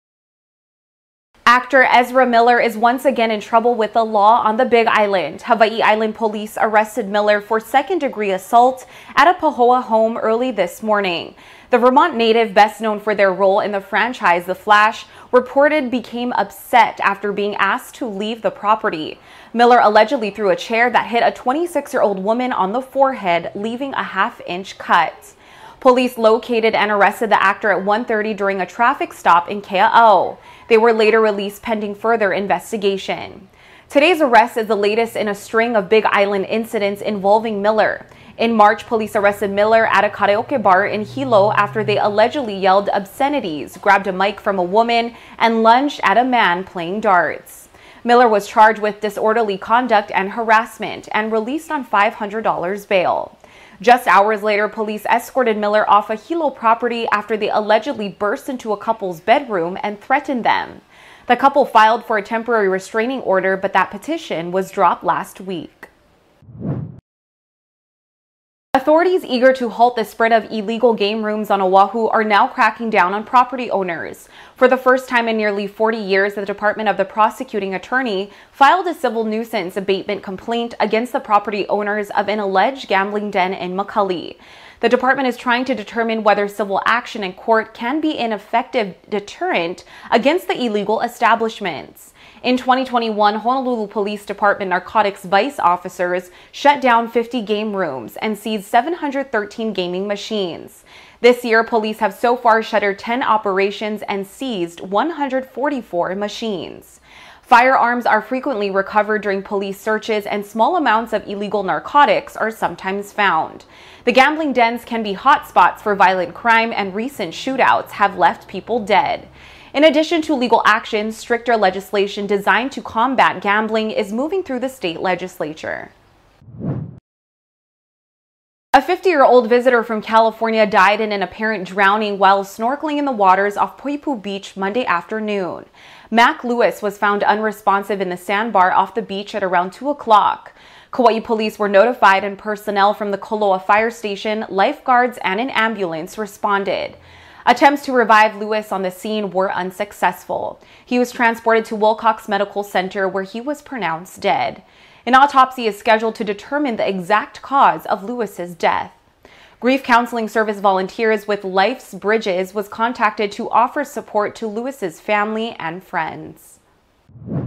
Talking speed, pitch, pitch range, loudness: 155 wpm, 215 Hz, 200-240 Hz, -17 LUFS